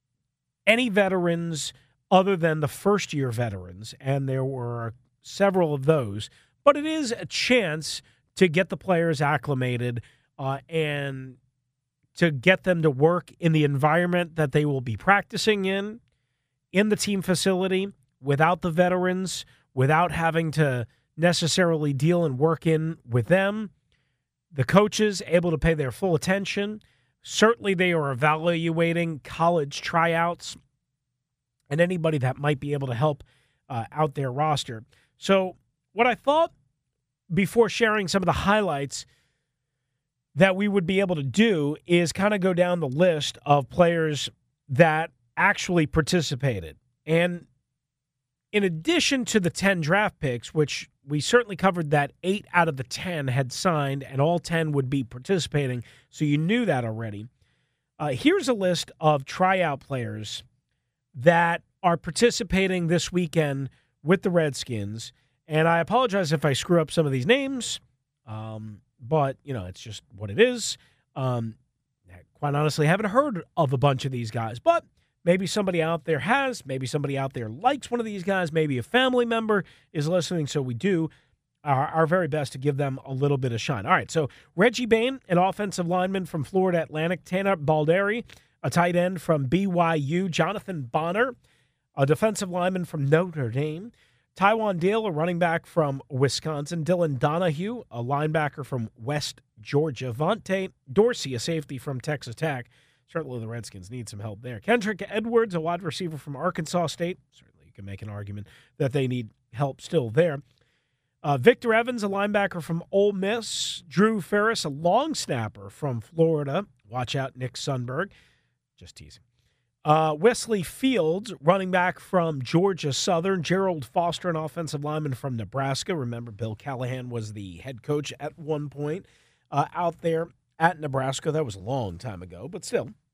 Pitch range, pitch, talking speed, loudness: 130-185 Hz, 155 Hz, 160 wpm, -25 LUFS